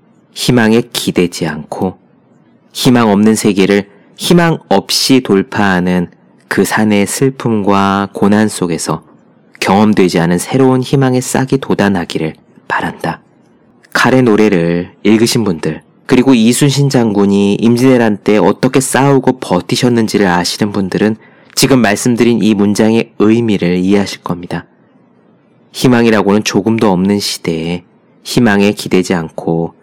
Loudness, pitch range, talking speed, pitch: -11 LUFS, 95-120 Hz, 280 characters per minute, 105 Hz